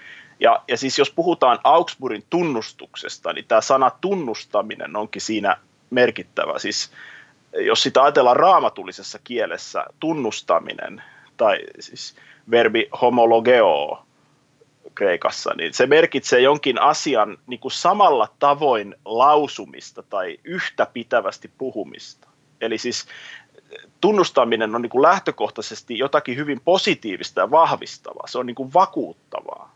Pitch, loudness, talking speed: 150 Hz, -19 LUFS, 115 wpm